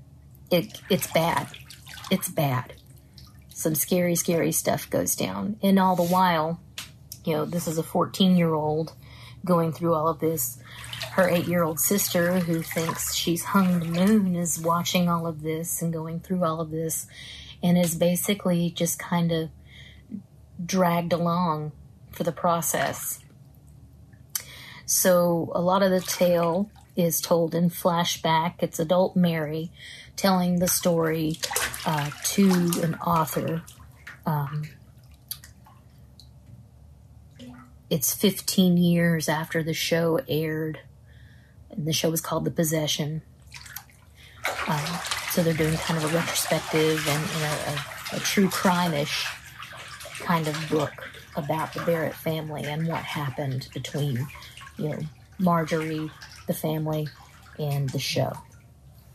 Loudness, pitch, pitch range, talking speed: -25 LUFS, 165 Hz, 155-175 Hz, 130 wpm